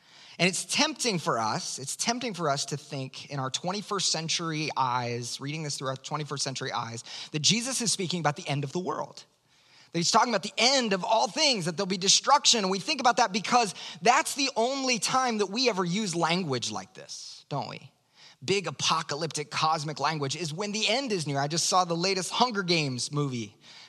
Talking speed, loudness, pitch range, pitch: 210 wpm, -27 LUFS, 145-220 Hz, 175 Hz